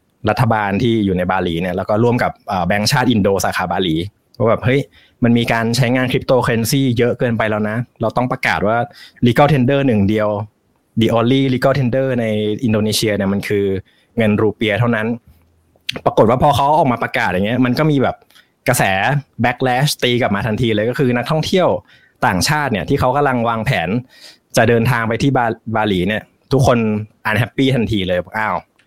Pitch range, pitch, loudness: 105-125 Hz, 115 Hz, -16 LUFS